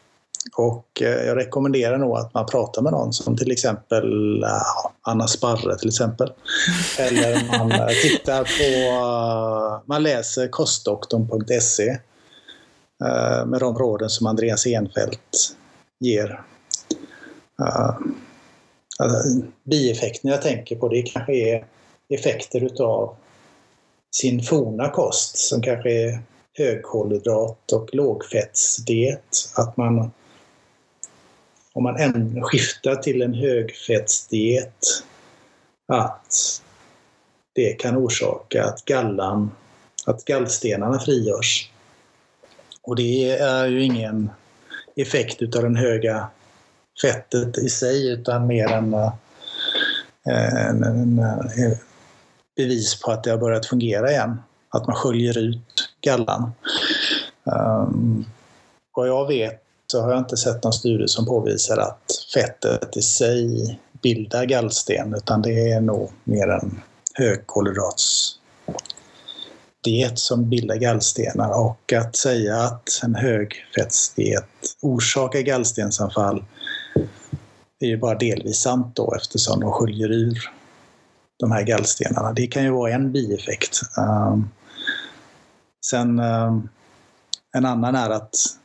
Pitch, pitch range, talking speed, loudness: 120 Hz, 110-125 Hz, 110 wpm, -21 LUFS